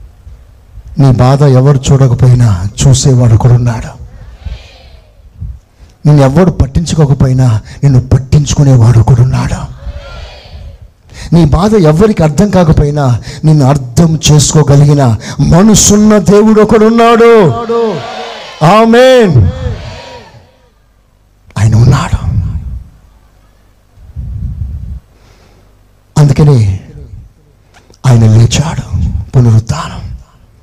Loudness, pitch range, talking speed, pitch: -7 LUFS, 100-150 Hz, 55 wpm, 125 Hz